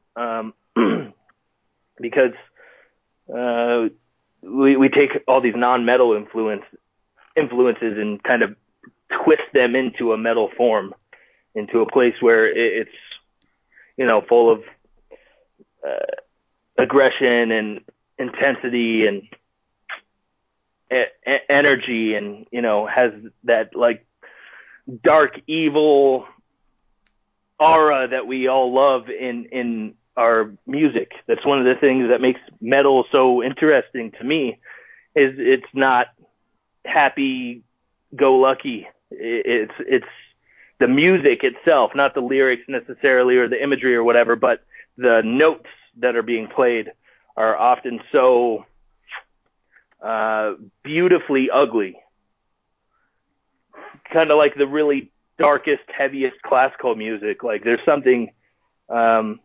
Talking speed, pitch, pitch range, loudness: 110 wpm, 130 Hz, 120-155 Hz, -18 LUFS